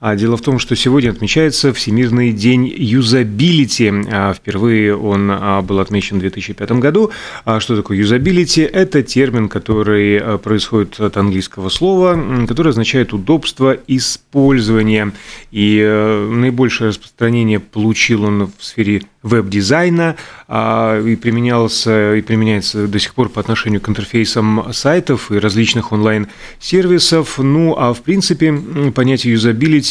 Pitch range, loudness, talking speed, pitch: 105-135 Hz, -13 LUFS, 120 wpm, 115 Hz